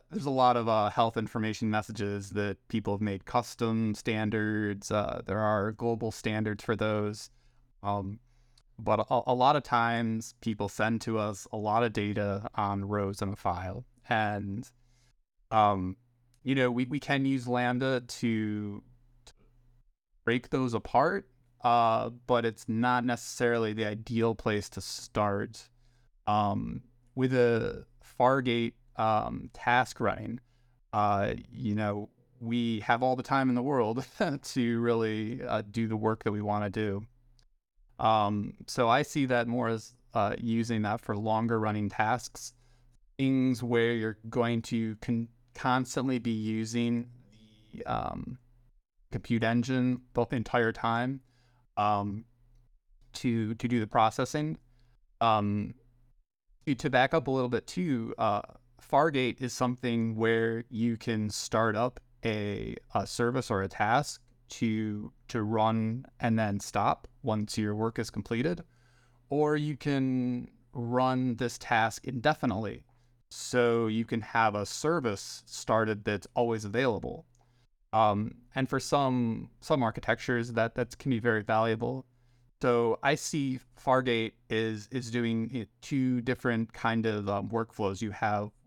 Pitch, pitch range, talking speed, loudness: 115 Hz, 110-125 Hz, 145 wpm, -30 LUFS